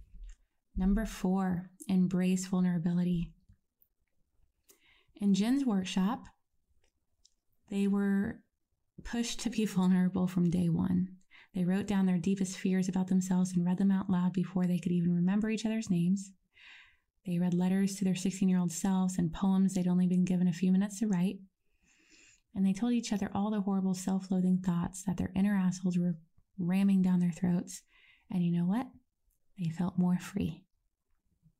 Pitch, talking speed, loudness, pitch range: 185 Hz, 160 wpm, -31 LUFS, 180-195 Hz